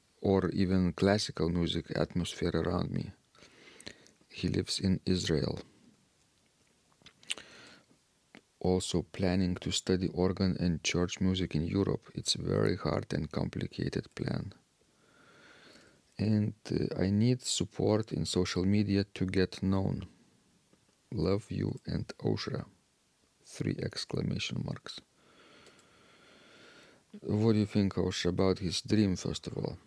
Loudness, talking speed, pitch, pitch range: -32 LUFS, 115 wpm, 95 Hz, 90-100 Hz